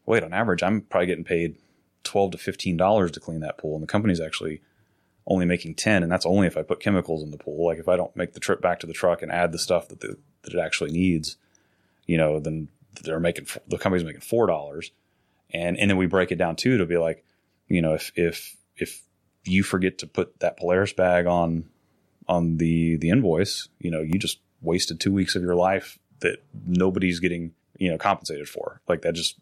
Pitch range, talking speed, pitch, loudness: 80-95 Hz, 225 wpm, 85 Hz, -25 LUFS